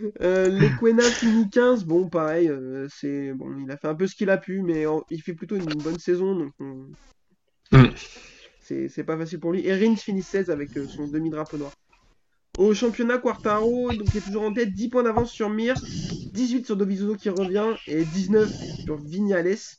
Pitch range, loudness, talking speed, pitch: 155-215 Hz, -24 LUFS, 195 wpm, 190 Hz